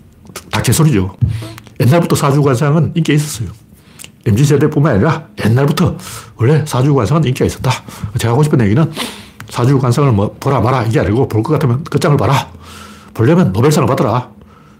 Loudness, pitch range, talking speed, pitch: -13 LUFS, 110-150 Hz, 365 characters per minute, 130 Hz